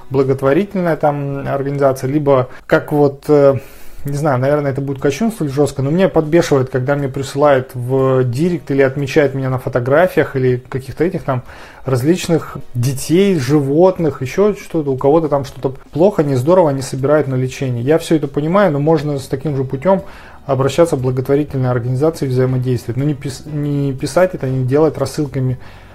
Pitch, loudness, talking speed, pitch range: 140 Hz, -15 LUFS, 155 wpm, 135-155 Hz